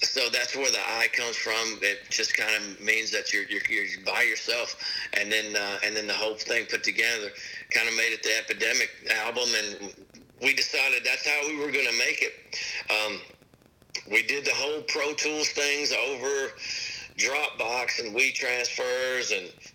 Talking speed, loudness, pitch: 180 wpm, -26 LUFS, 145 Hz